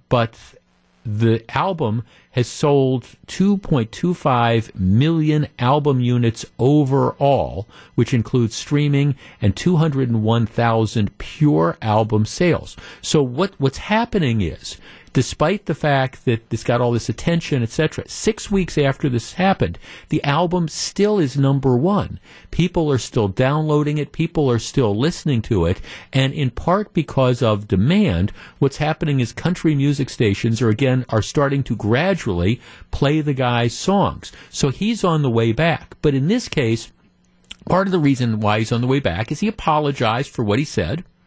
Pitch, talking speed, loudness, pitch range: 135 Hz, 155 wpm, -19 LUFS, 115-155 Hz